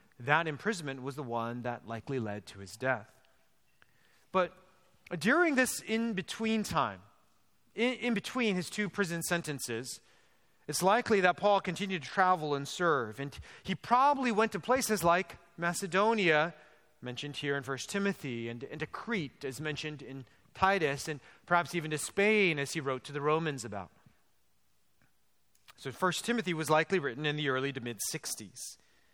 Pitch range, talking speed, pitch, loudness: 135-195 Hz, 160 wpm, 155 Hz, -32 LUFS